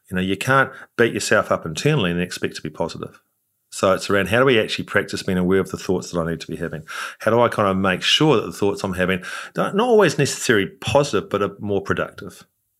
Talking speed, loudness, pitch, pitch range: 250 wpm, -20 LUFS, 95 Hz, 90-115 Hz